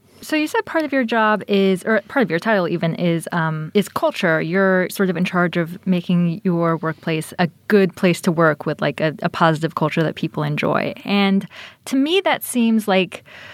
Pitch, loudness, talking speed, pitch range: 185 Hz, -19 LUFS, 210 wpm, 165-215 Hz